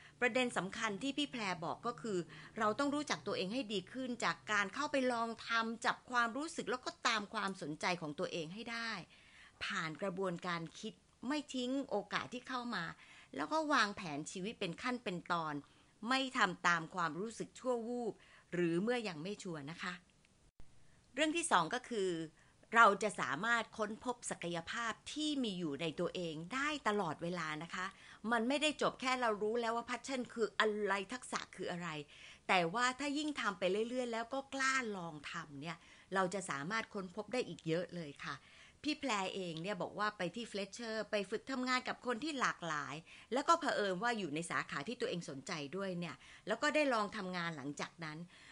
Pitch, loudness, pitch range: 210 Hz, -38 LUFS, 175-245 Hz